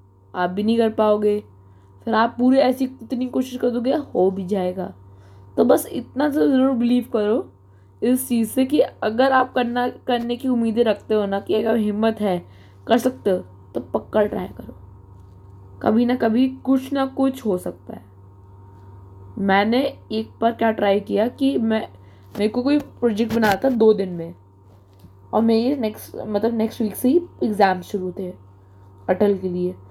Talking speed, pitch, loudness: 175 wpm, 210 Hz, -21 LUFS